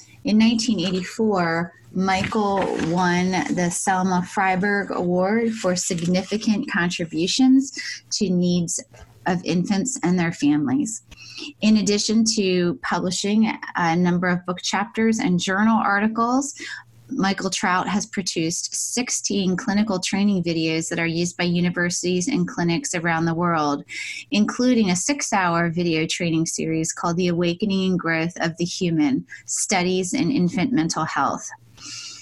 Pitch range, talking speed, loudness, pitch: 175-210 Hz, 125 wpm, -21 LUFS, 185 Hz